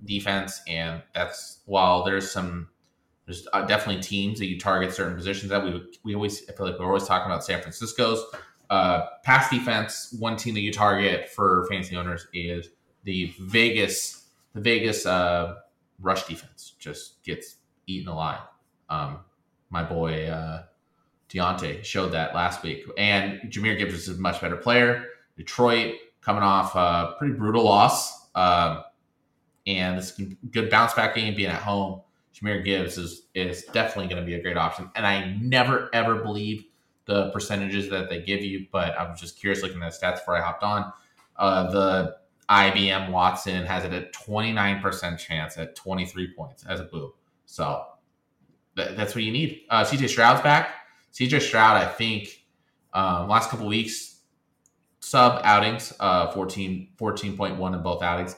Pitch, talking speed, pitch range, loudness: 95 Hz, 165 wpm, 90-110 Hz, -24 LUFS